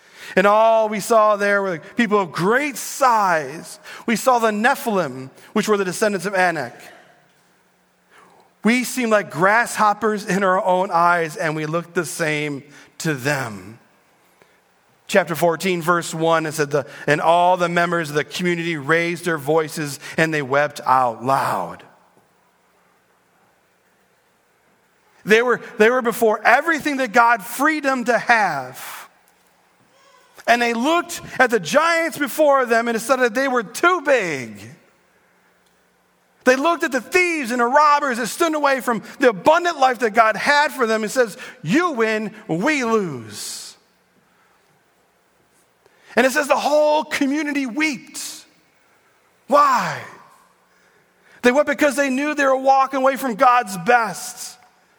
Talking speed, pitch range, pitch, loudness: 140 wpm, 175-270 Hz, 230 Hz, -18 LUFS